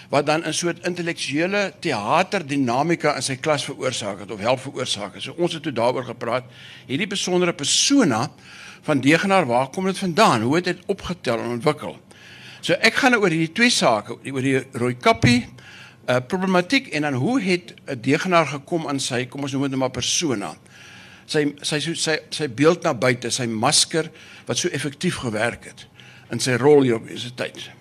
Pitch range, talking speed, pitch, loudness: 130-175 Hz, 185 wpm, 150 Hz, -21 LUFS